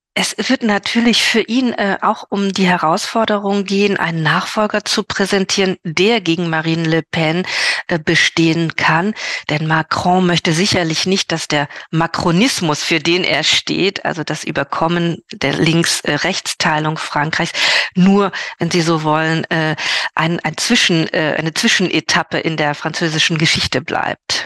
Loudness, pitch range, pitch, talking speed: -15 LUFS, 160-195 Hz, 170 Hz, 140 wpm